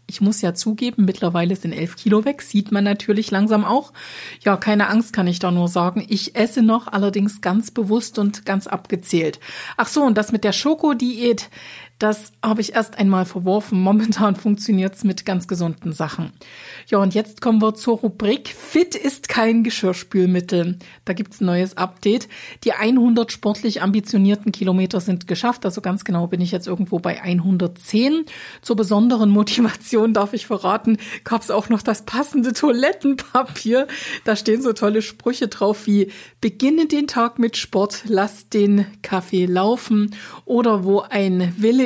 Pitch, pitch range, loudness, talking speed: 210 Hz, 195-230 Hz, -19 LUFS, 170 wpm